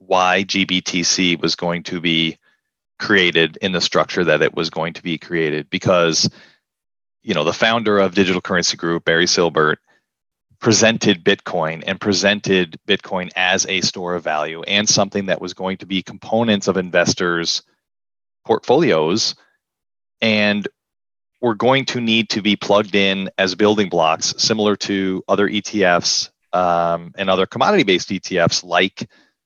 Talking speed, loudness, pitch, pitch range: 145 wpm, -17 LUFS, 95 Hz, 85-100 Hz